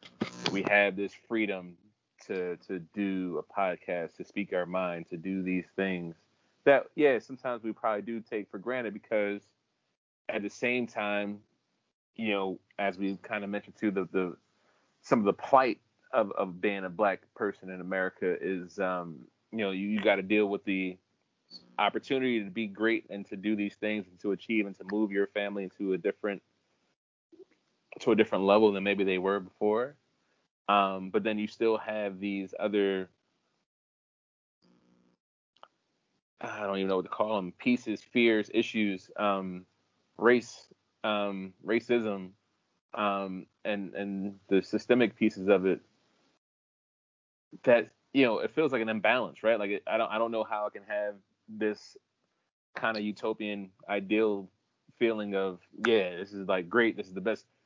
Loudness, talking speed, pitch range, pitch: -31 LUFS, 165 wpm, 95-110 Hz, 100 Hz